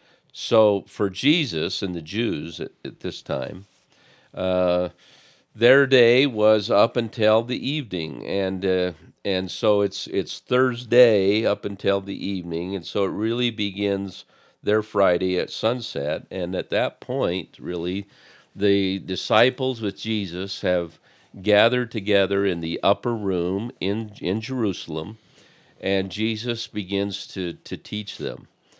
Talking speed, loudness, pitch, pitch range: 130 wpm, -23 LUFS, 100 Hz, 95-110 Hz